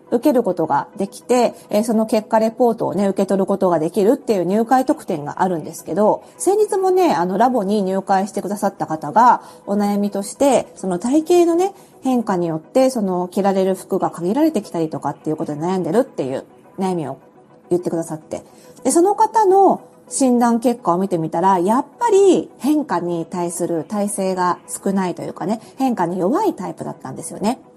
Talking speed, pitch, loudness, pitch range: 385 characters per minute, 200 Hz, -18 LUFS, 175-255 Hz